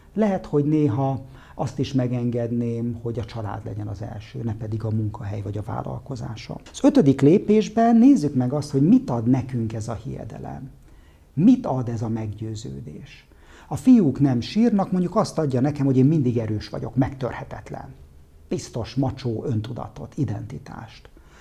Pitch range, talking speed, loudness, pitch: 110-145 Hz, 155 wpm, -22 LUFS, 125 Hz